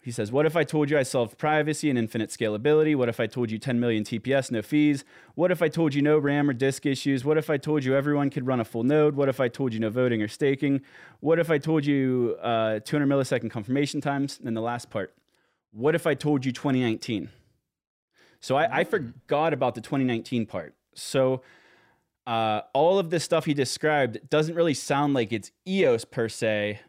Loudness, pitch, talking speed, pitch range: -25 LUFS, 135 Hz, 220 wpm, 115-150 Hz